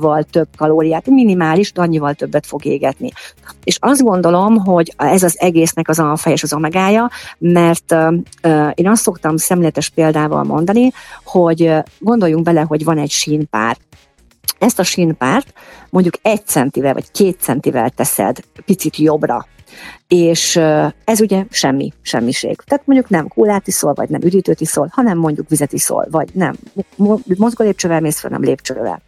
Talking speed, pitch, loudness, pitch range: 155 wpm, 170 Hz, -14 LUFS, 155-195 Hz